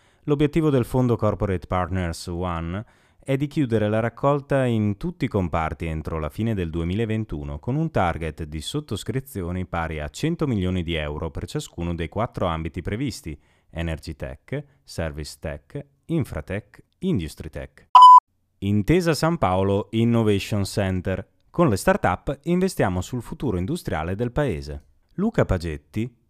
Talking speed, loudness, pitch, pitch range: 135 wpm, -23 LUFS, 100 Hz, 85-135 Hz